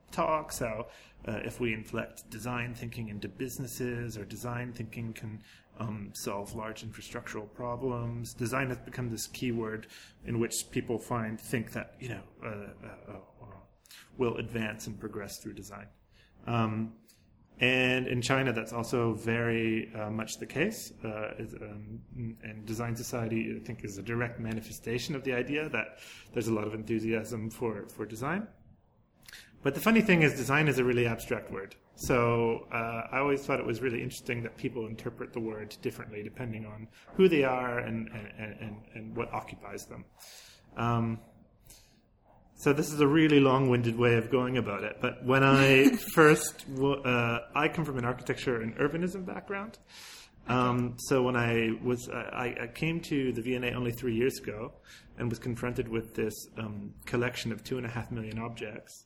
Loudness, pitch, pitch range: -31 LUFS, 115 Hz, 110-125 Hz